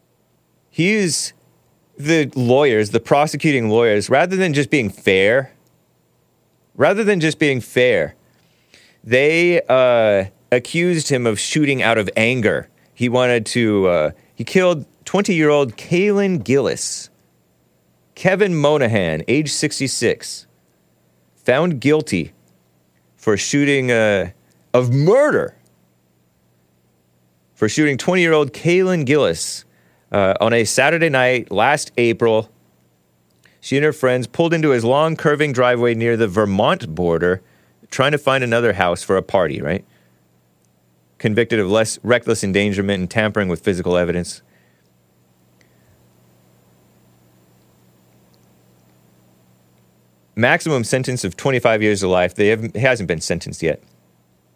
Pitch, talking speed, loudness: 110 Hz, 115 wpm, -17 LUFS